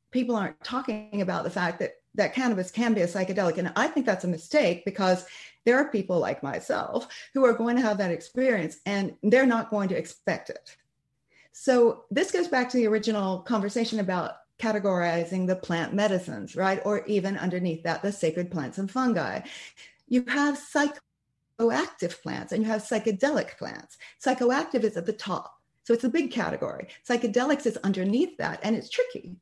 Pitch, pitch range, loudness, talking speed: 220 Hz, 185-255 Hz, -27 LUFS, 180 wpm